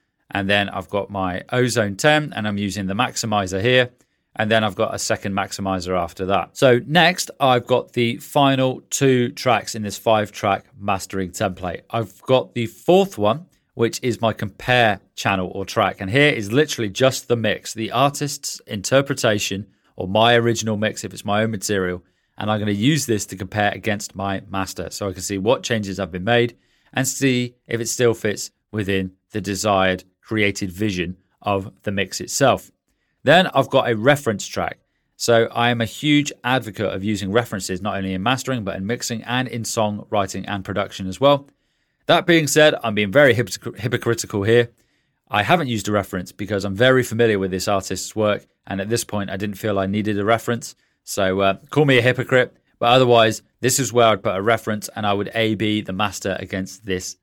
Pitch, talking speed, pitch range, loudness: 110 Hz, 195 wpm, 100-125 Hz, -20 LUFS